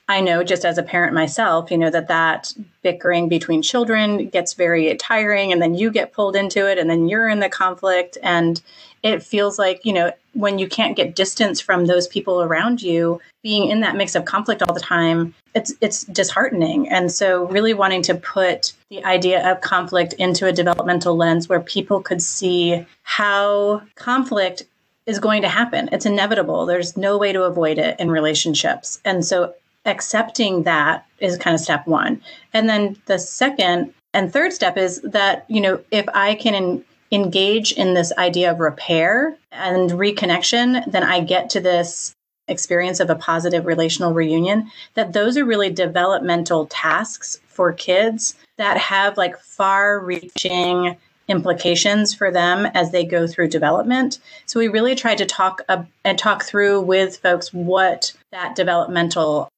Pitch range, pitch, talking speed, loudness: 175-210 Hz, 185 Hz, 170 wpm, -18 LUFS